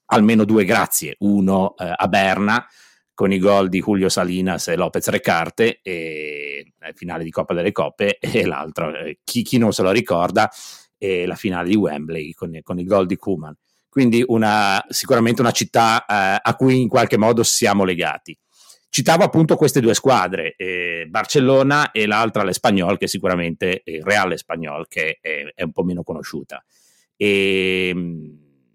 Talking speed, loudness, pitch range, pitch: 170 wpm, -18 LUFS, 90-120 Hz, 100 Hz